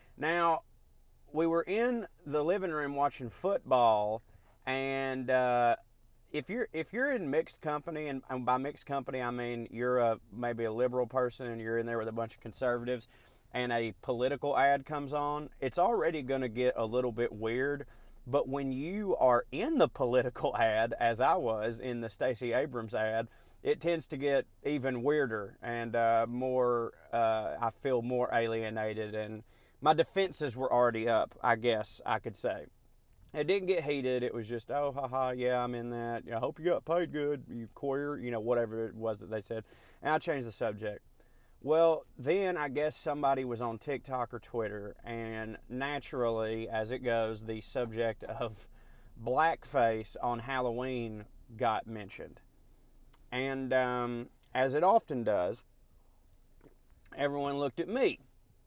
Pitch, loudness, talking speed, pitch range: 125 Hz, -33 LUFS, 165 wpm, 115-145 Hz